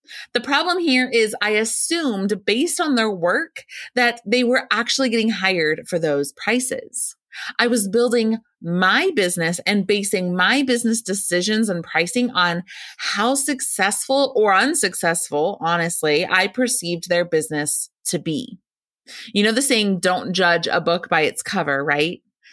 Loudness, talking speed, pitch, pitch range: -19 LUFS, 145 wpm, 210 Hz, 175-245 Hz